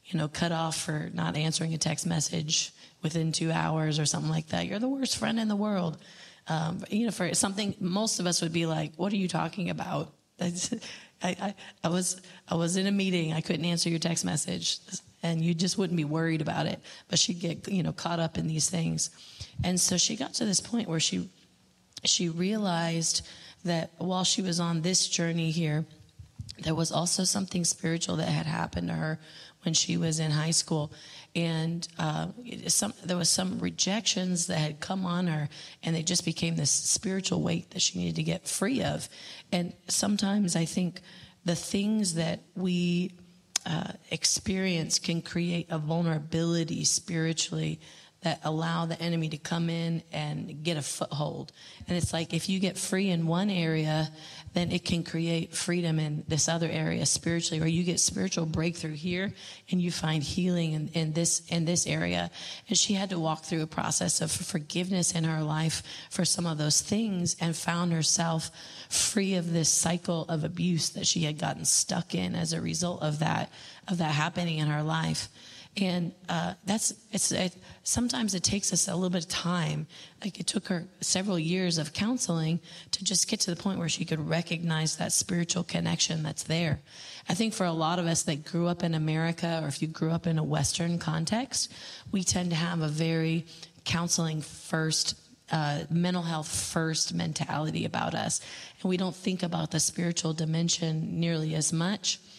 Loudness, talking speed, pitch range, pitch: -29 LUFS, 190 wpm, 160-180 Hz, 170 Hz